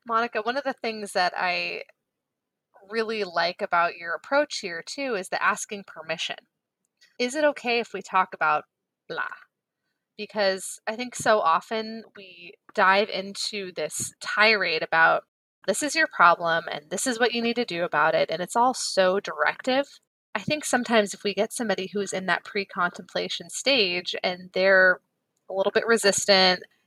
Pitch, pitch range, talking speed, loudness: 200 Hz, 180-235 Hz, 165 wpm, -24 LUFS